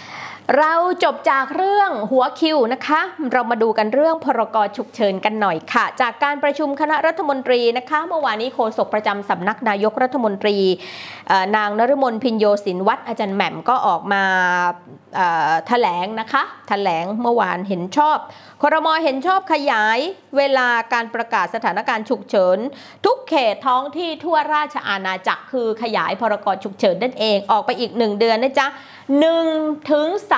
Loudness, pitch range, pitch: -18 LUFS, 215-300 Hz, 250 Hz